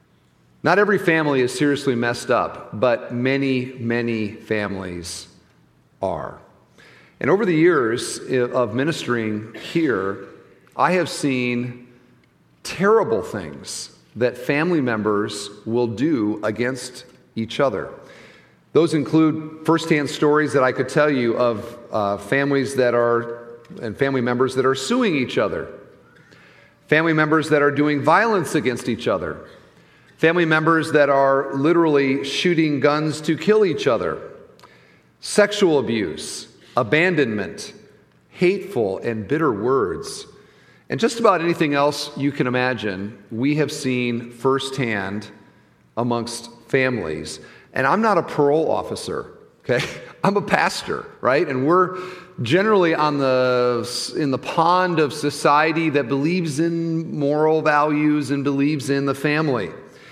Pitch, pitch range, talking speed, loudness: 140 Hz, 120-160 Hz, 125 wpm, -20 LUFS